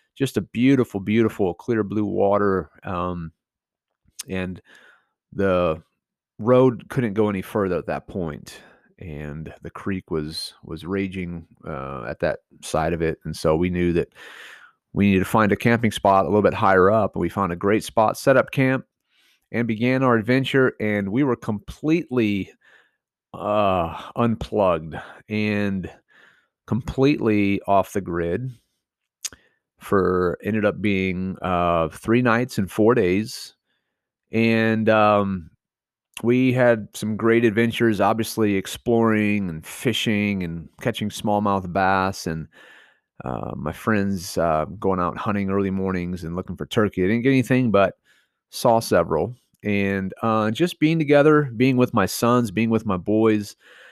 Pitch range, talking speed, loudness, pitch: 95-115 Hz, 145 wpm, -22 LUFS, 105 Hz